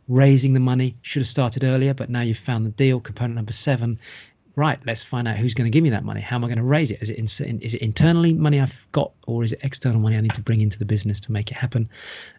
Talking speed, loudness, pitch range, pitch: 285 wpm, -21 LUFS, 110-135 Hz, 120 Hz